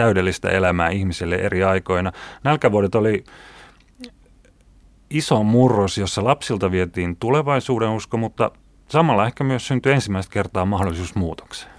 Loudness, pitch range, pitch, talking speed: -20 LUFS, 95-125 Hz, 100 Hz, 115 wpm